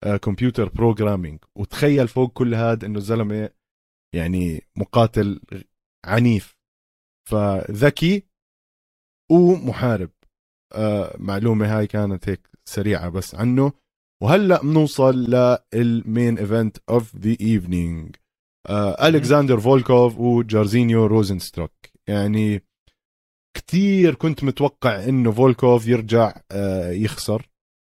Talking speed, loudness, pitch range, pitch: 90 wpm, -19 LUFS, 100-125 Hz, 110 Hz